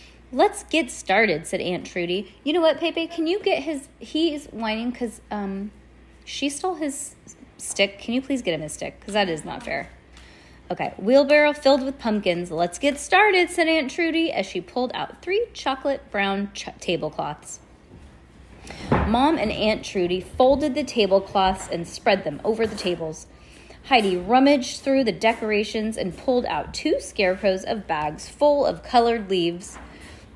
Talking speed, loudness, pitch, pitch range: 165 wpm, -23 LUFS, 230 Hz, 190-295 Hz